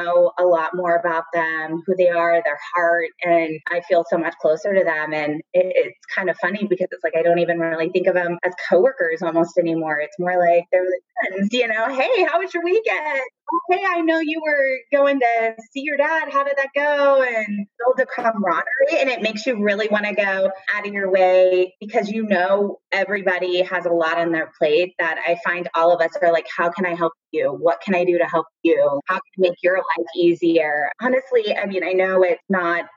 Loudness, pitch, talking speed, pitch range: -19 LUFS, 185 Hz, 225 wpm, 170-230 Hz